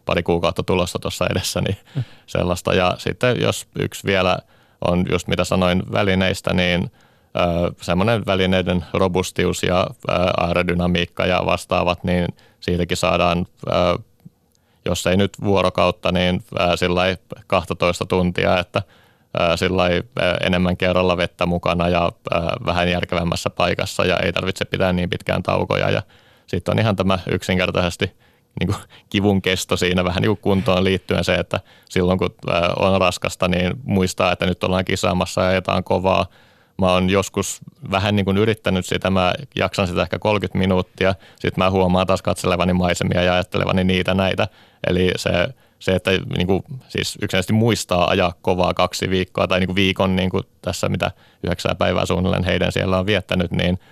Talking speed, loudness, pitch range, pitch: 150 wpm, -20 LUFS, 90-95 Hz, 90 Hz